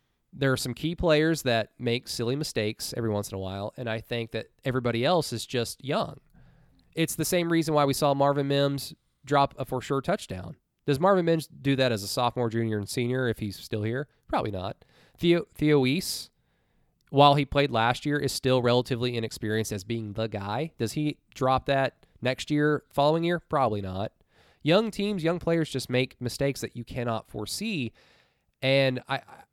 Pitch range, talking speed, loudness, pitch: 115-150 Hz, 190 wpm, -27 LUFS, 130 Hz